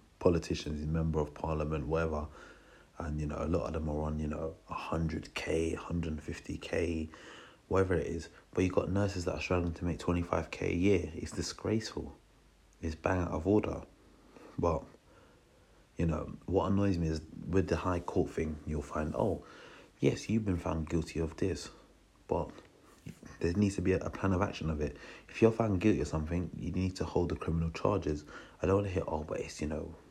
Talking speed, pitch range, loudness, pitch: 195 wpm, 80-90 Hz, -34 LUFS, 80 Hz